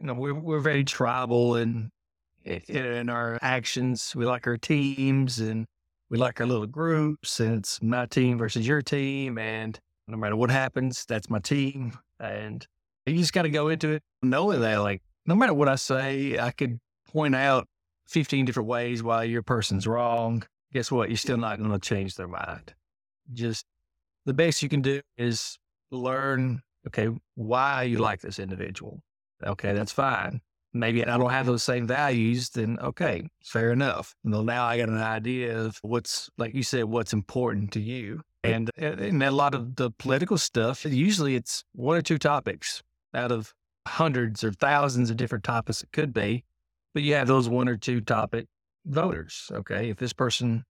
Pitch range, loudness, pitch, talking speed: 110-135 Hz, -27 LUFS, 120 Hz, 180 wpm